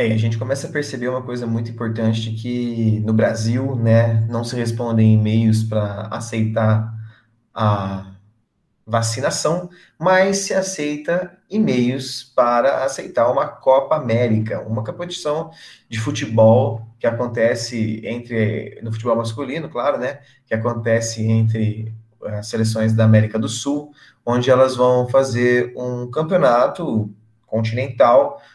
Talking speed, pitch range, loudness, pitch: 125 wpm, 110-130 Hz, -19 LUFS, 115 Hz